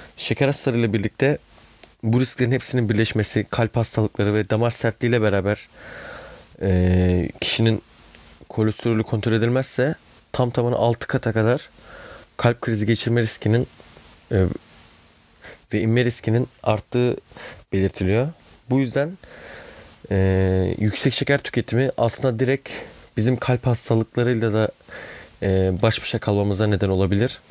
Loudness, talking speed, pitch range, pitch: -21 LUFS, 115 wpm, 105-125 Hz, 115 Hz